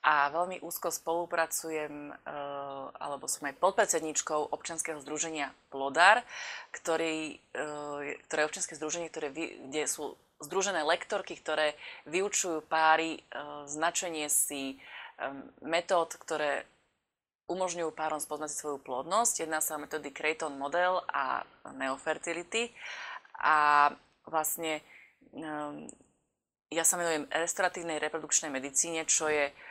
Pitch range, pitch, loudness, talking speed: 150-170 Hz, 155 Hz, -31 LUFS, 110 wpm